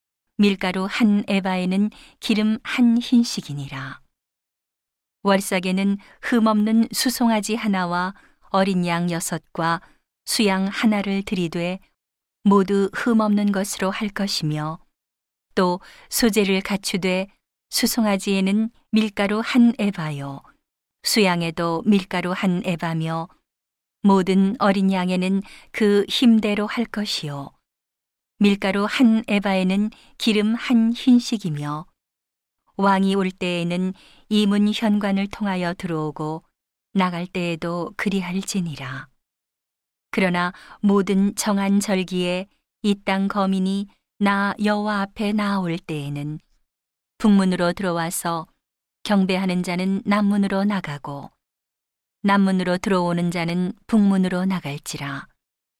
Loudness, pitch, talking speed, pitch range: -21 LUFS, 195 Hz, 225 characters per minute, 175-210 Hz